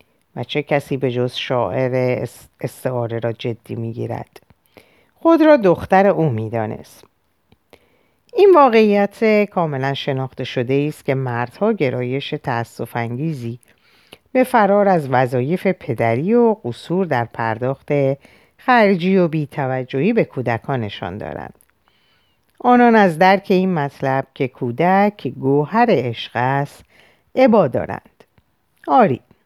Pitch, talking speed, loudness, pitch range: 140 Hz, 115 wpm, -17 LUFS, 125-195 Hz